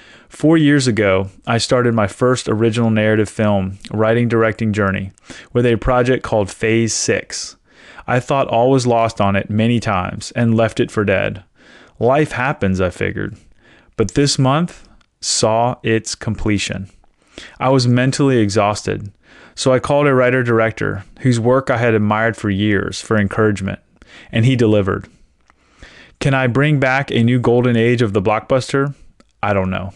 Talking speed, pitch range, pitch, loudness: 160 wpm, 105-125 Hz, 115 Hz, -16 LUFS